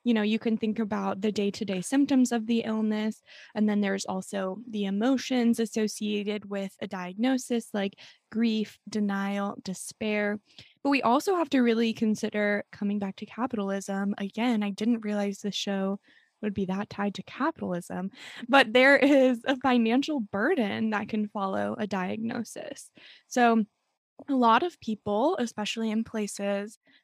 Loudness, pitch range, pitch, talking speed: -28 LUFS, 200-240 Hz, 220 Hz, 150 wpm